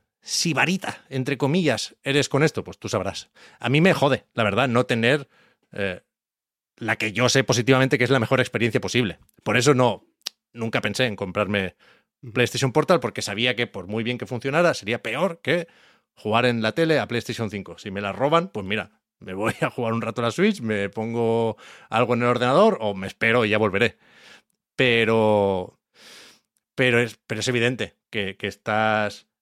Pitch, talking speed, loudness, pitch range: 120 Hz, 190 wpm, -22 LUFS, 110-130 Hz